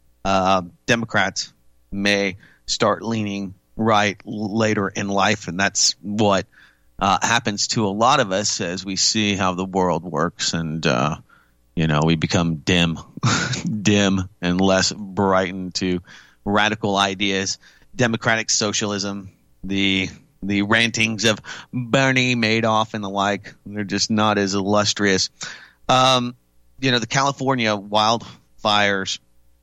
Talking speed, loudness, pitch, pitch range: 125 wpm, -20 LUFS, 100 Hz, 95-110 Hz